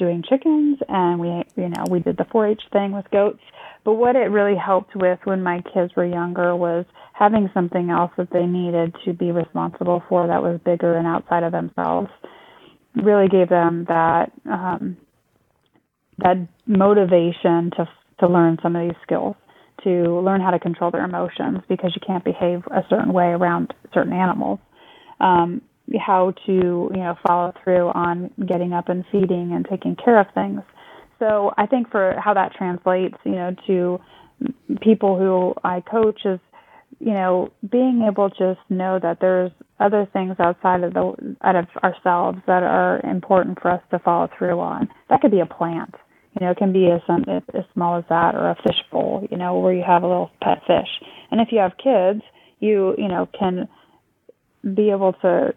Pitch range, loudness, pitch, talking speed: 175-200 Hz, -20 LUFS, 180 Hz, 185 wpm